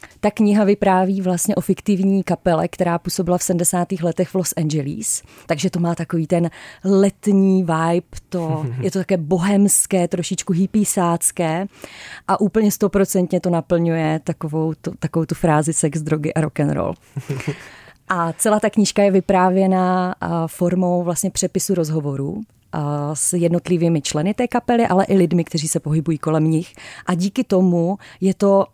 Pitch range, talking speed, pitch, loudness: 165-190 Hz, 150 wpm, 180 Hz, -19 LUFS